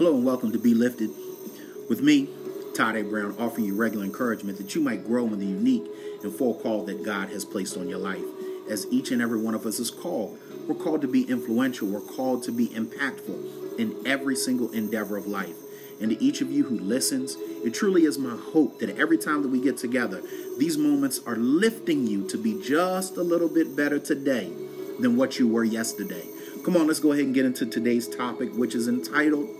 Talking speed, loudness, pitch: 215 wpm, -26 LUFS, 145 Hz